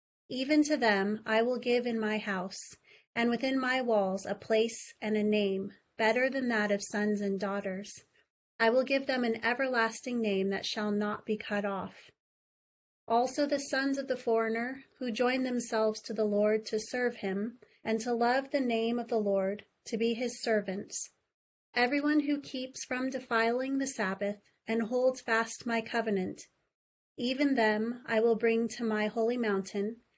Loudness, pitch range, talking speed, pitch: -31 LUFS, 210-250 Hz, 170 wpm, 230 Hz